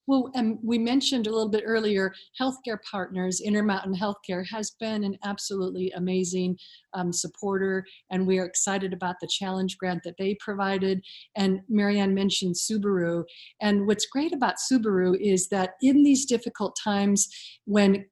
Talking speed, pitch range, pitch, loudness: 150 wpm, 185-220 Hz, 195 Hz, -26 LUFS